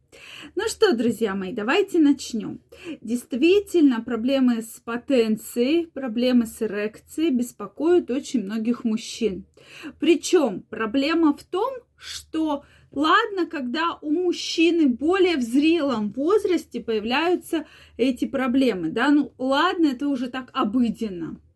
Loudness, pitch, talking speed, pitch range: -23 LUFS, 275 Hz, 110 wpm, 235-330 Hz